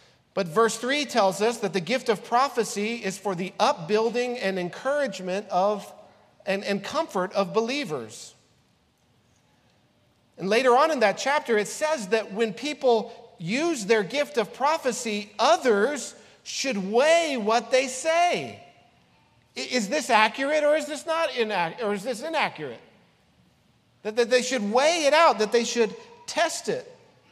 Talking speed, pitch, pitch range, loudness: 150 wpm, 235 Hz, 210-290 Hz, -24 LUFS